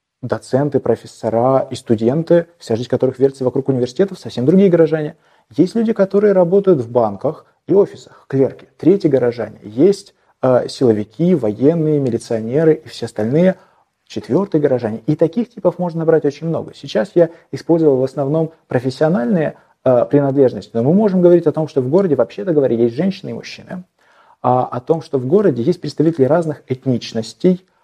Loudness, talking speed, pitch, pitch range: -16 LUFS, 155 wpm, 150 Hz, 125-170 Hz